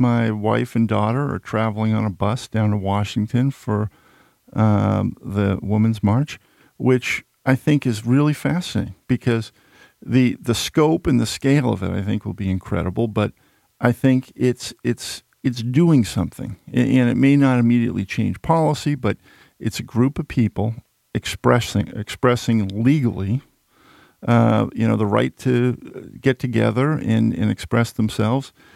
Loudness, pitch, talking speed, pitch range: -20 LUFS, 115 Hz, 150 wpm, 105-130 Hz